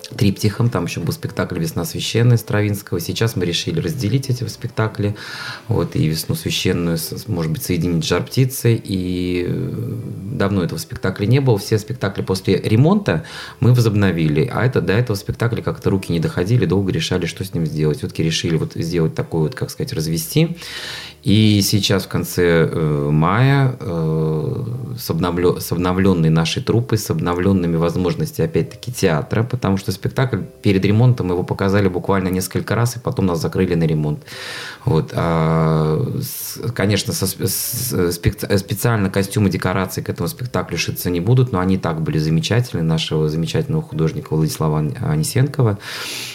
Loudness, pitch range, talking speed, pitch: -19 LUFS, 90-120 Hz, 150 wpm, 100 Hz